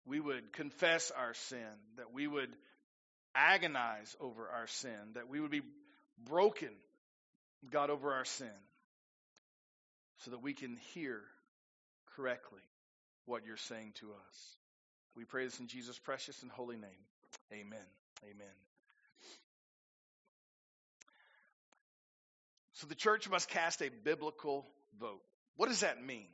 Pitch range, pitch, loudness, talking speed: 105-145 Hz, 125 Hz, -39 LUFS, 125 wpm